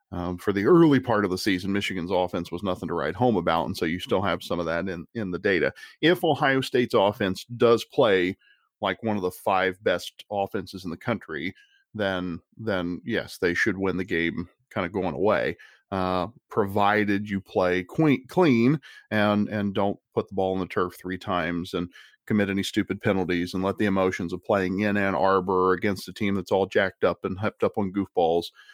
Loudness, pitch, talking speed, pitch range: -25 LUFS, 95 Hz, 205 wpm, 90-105 Hz